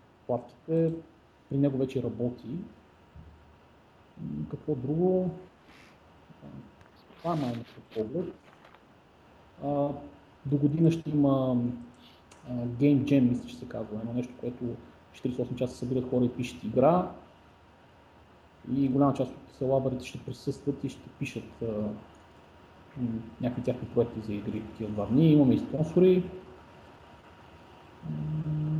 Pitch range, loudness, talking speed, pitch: 115-140 Hz, -30 LUFS, 110 wpm, 125 Hz